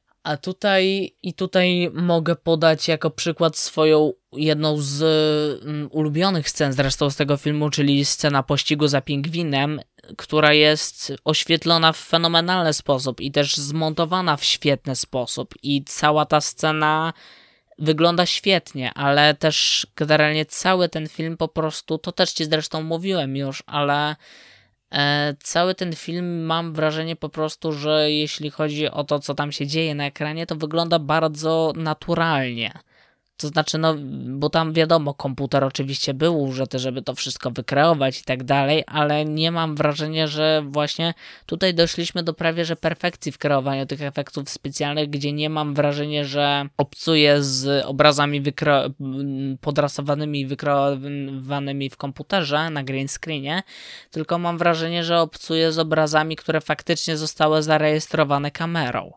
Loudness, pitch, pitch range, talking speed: -21 LUFS, 150 Hz, 145-165 Hz, 140 wpm